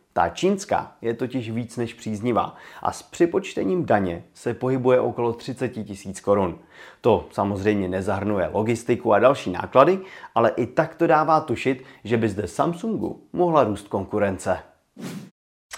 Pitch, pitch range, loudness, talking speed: 120 Hz, 100-130 Hz, -23 LUFS, 140 wpm